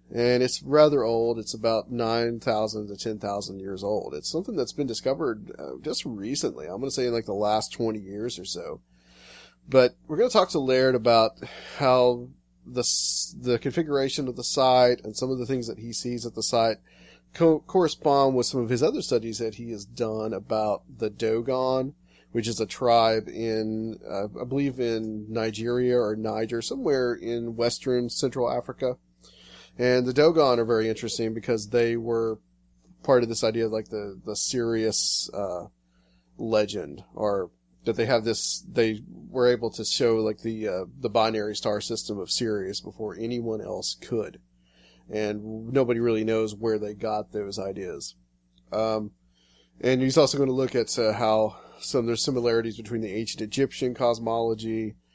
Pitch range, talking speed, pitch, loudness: 105-125 Hz, 175 wpm, 115 Hz, -26 LUFS